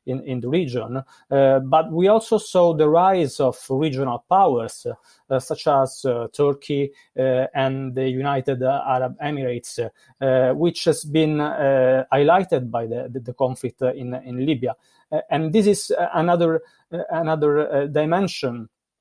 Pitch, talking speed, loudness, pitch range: 135 Hz, 145 wpm, -21 LUFS, 130-160 Hz